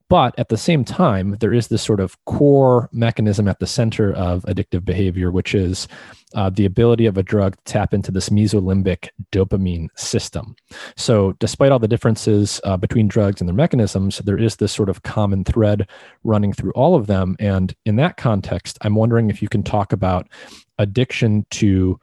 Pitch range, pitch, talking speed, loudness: 95-115 Hz, 105 Hz, 190 wpm, -18 LUFS